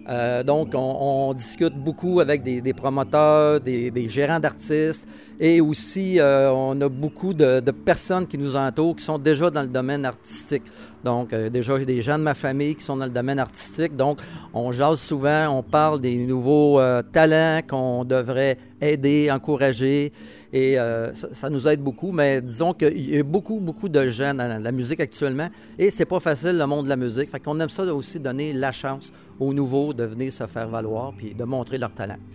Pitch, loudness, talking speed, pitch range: 140 Hz, -22 LUFS, 210 wpm, 125-150 Hz